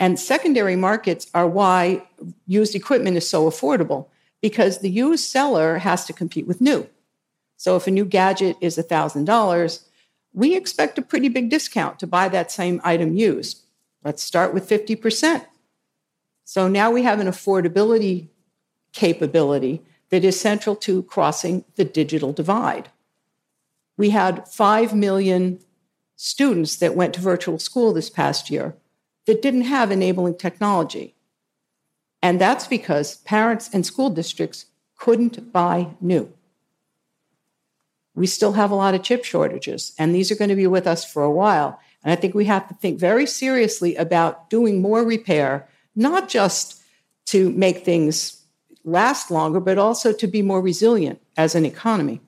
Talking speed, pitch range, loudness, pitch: 155 wpm, 170-220 Hz, -20 LUFS, 190 Hz